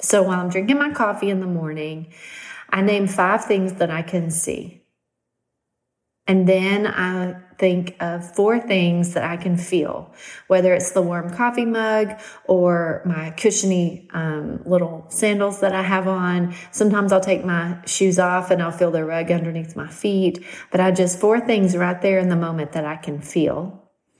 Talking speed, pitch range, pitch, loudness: 180 wpm, 170-195 Hz, 180 Hz, -20 LUFS